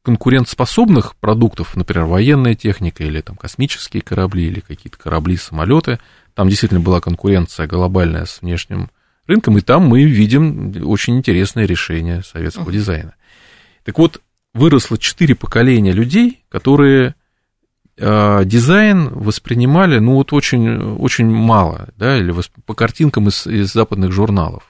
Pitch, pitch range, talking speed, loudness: 105 Hz, 90-125 Hz, 125 wpm, -14 LUFS